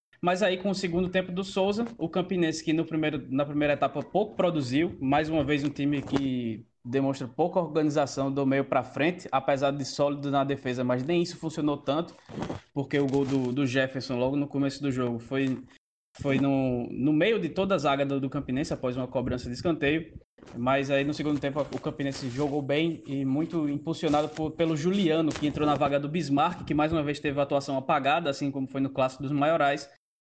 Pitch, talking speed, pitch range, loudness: 145 Hz, 205 wpm, 135-155 Hz, -28 LUFS